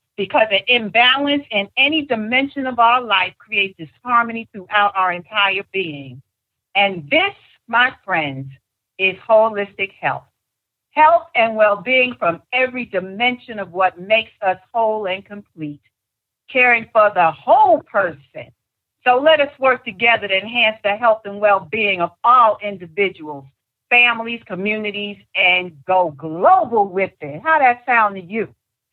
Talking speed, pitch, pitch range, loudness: 135 wpm, 205 Hz, 185-235 Hz, -16 LUFS